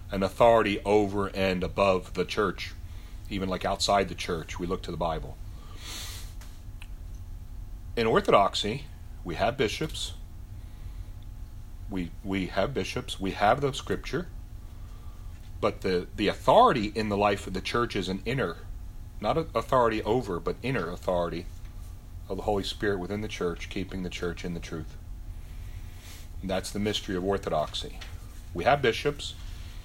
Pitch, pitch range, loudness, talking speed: 95 Hz, 85-100 Hz, -28 LUFS, 145 wpm